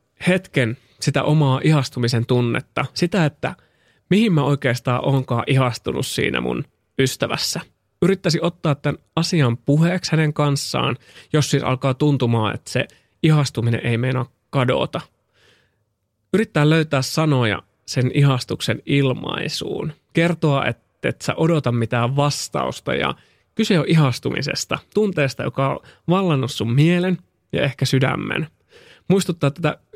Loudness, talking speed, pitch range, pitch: -20 LUFS, 120 wpm, 120-155 Hz, 140 Hz